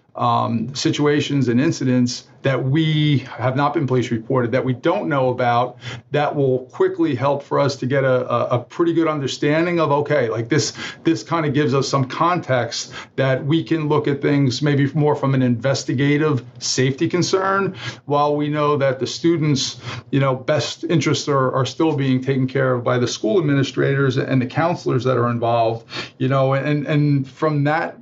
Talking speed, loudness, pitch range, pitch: 185 wpm, -19 LUFS, 125-150 Hz, 135 Hz